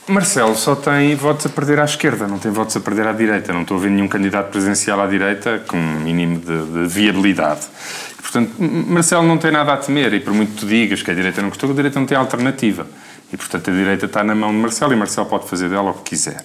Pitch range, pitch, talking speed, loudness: 100-145 Hz, 105 Hz, 260 wpm, -17 LUFS